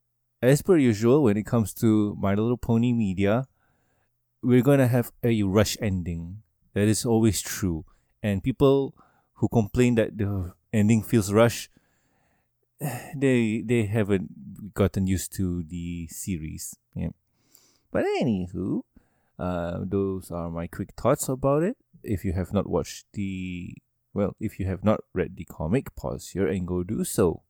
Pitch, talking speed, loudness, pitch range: 105 Hz, 150 wpm, -25 LUFS, 95-120 Hz